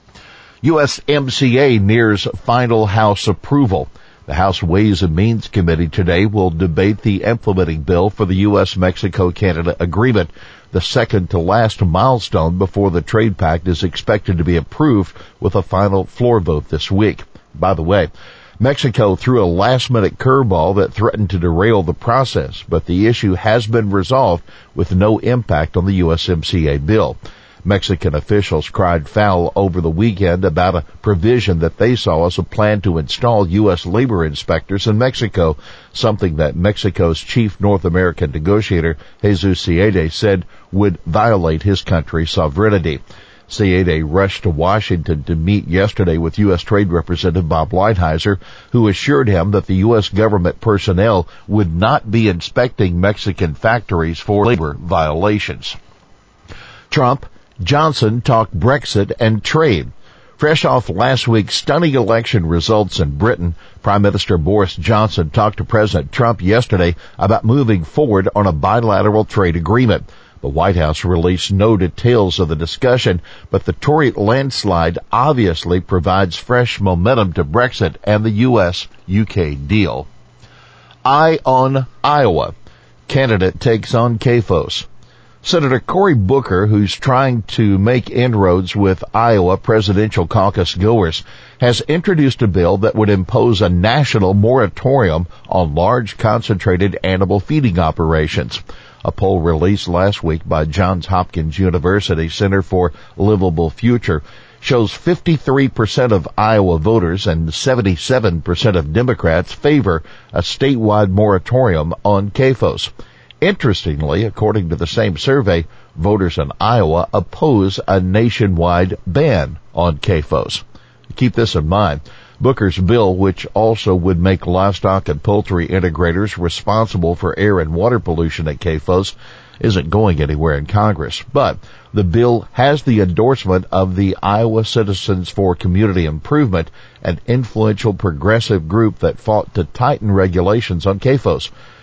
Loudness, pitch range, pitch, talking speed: -15 LUFS, 90-110 Hz, 100 Hz, 135 wpm